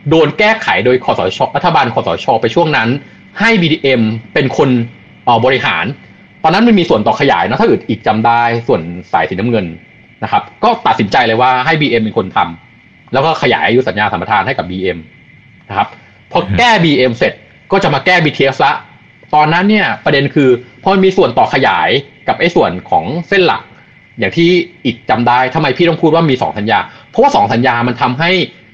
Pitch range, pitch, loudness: 120-175 Hz, 145 Hz, -11 LUFS